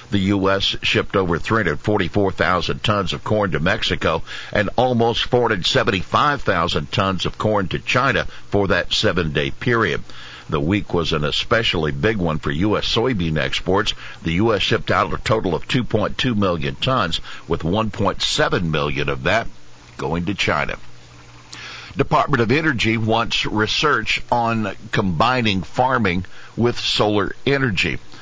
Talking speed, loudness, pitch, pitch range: 135 wpm, -19 LUFS, 100 Hz, 80-115 Hz